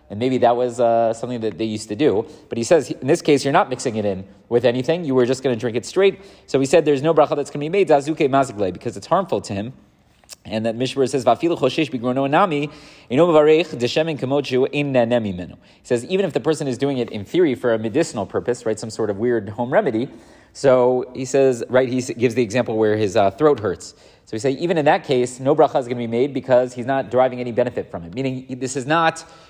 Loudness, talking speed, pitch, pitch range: -19 LUFS, 230 wpm, 130 Hz, 120-145 Hz